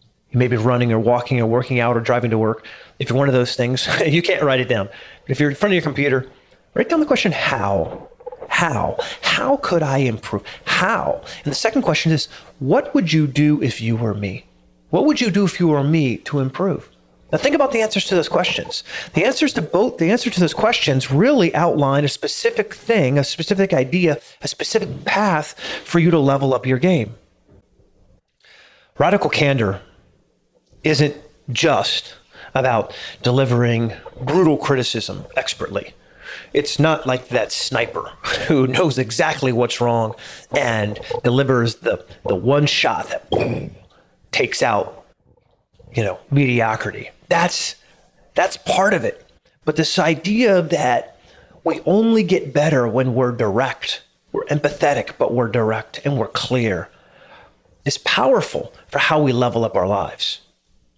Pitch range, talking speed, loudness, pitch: 120-170 Hz, 160 wpm, -19 LUFS, 140 Hz